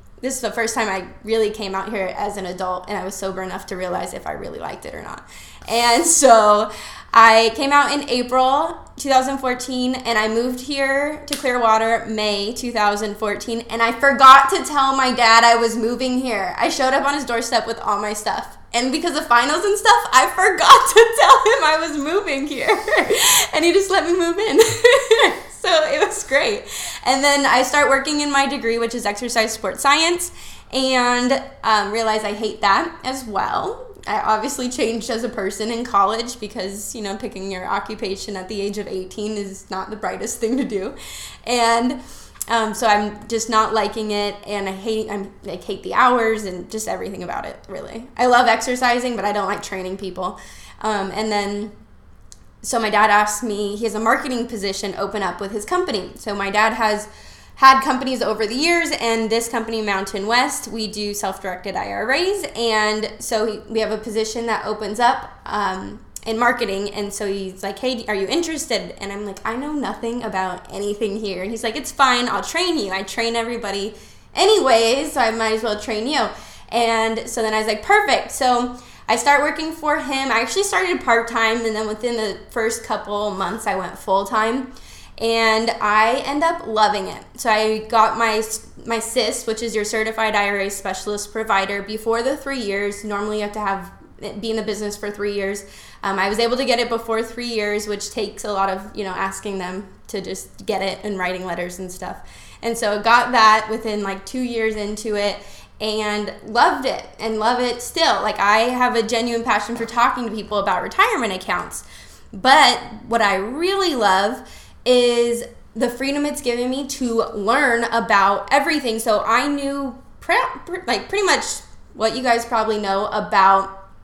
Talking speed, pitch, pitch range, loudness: 195 wpm, 225 Hz, 205-255 Hz, -19 LUFS